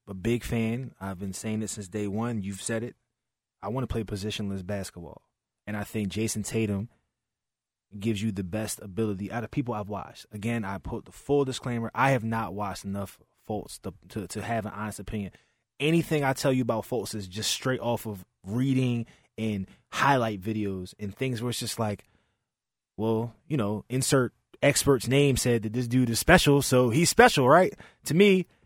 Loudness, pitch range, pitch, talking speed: -27 LUFS, 105-125 Hz, 110 Hz, 195 wpm